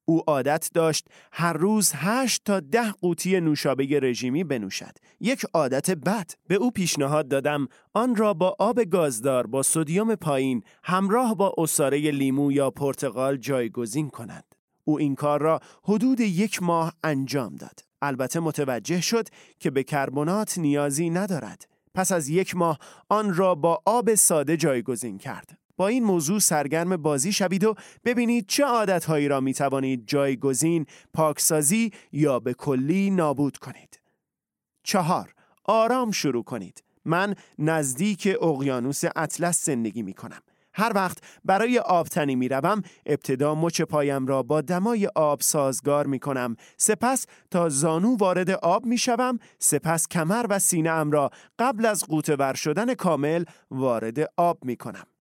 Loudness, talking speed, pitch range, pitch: -24 LUFS, 145 wpm, 140-195 Hz, 165 Hz